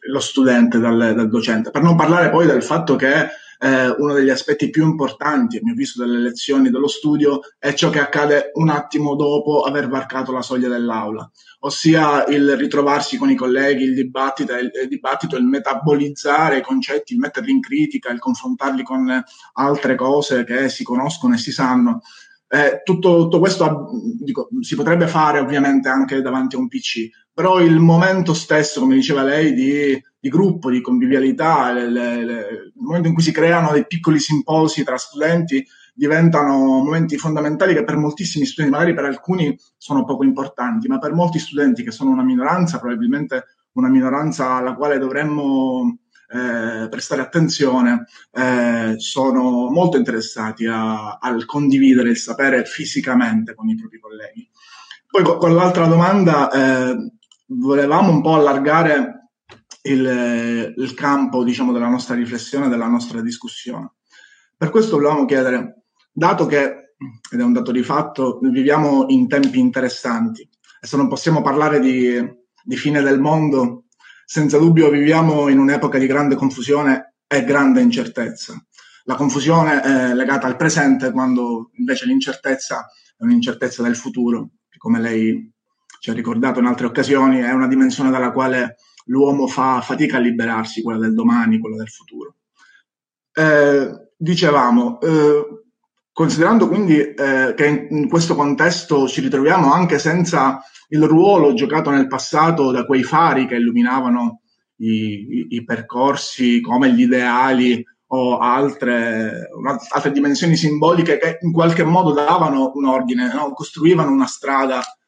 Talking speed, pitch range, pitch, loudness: 150 wpm, 130-175 Hz, 145 Hz, -16 LUFS